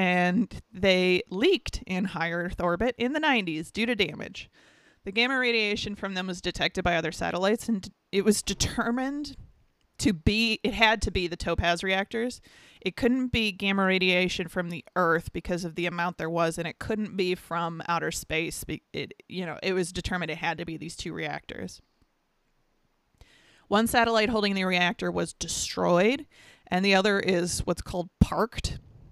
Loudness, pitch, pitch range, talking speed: -27 LUFS, 185 Hz, 175-220 Hz, 170 wpm